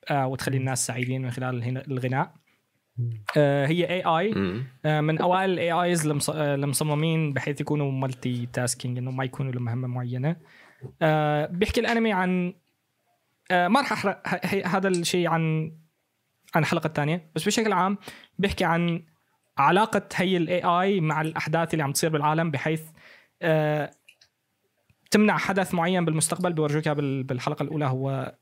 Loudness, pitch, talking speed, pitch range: -25 LUFS, 155 Hz, 145 wpm, 140-180 Hz